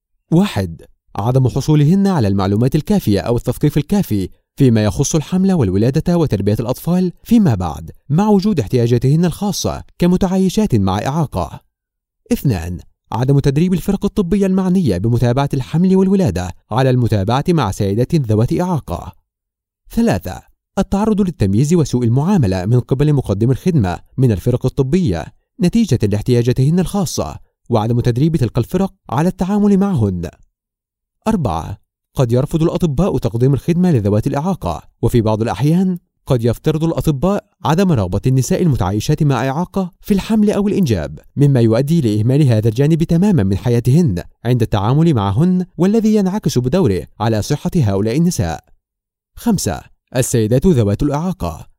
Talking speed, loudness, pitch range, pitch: 125 wpm, -16 LUFS, 110-180 Hz, 140 Hz